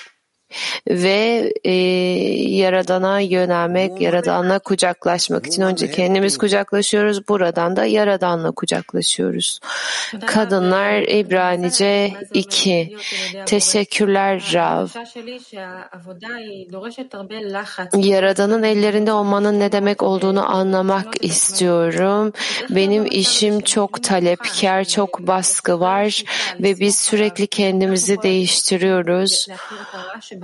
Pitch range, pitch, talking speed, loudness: 185-210 Hz, 195 Hz, 75 wpm, -17 LUFS